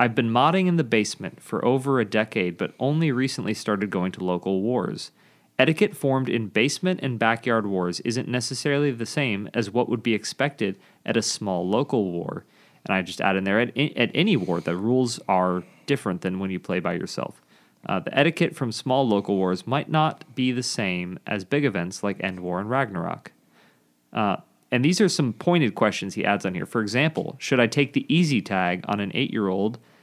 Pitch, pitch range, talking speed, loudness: 120 Hz, 100-140 Hz, 210 wpm, -24 LUFS